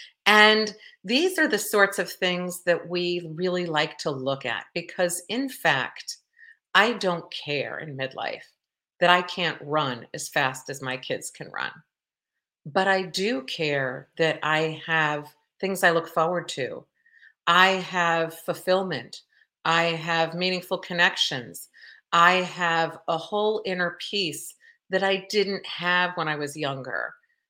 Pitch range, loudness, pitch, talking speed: 160-195 Hz, -24 LUFS, 175 Hz, 145 wpm